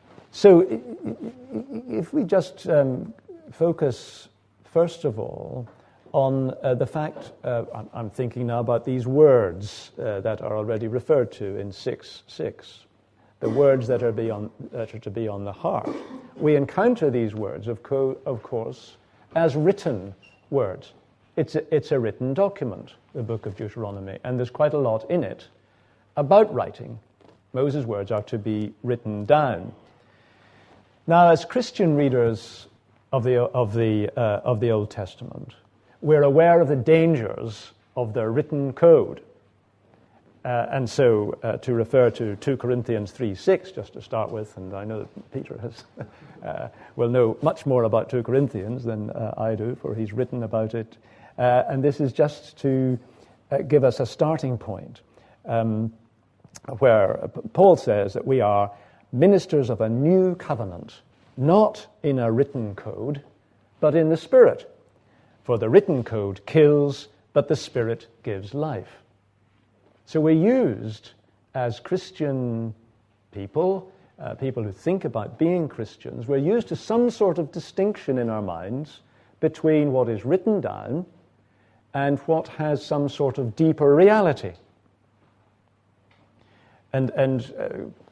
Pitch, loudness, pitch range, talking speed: 120 Hz, -23 LUFS, 110-150 Hz, 150 wpm